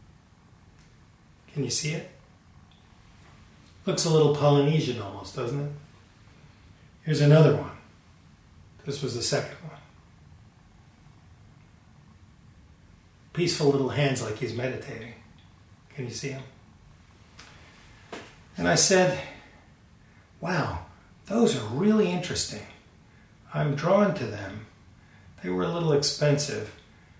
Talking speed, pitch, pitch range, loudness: 100 wpm, 120 Hz, 100-145 Hz, -25 LUFS